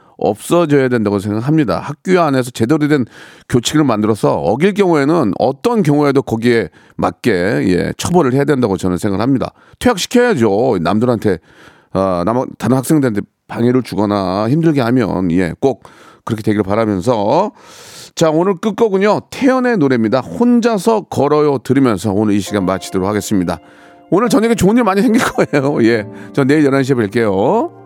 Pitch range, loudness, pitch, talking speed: 105-170 Hz, -14 LUFS, 130 Hz, 360 characters per minute